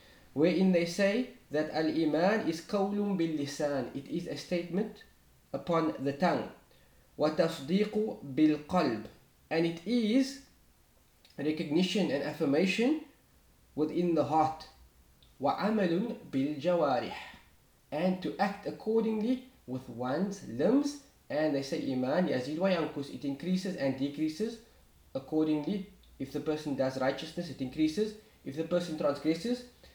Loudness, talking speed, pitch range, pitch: -32 LUFS, 110 wpm, 145-195 Hz, 160 Hz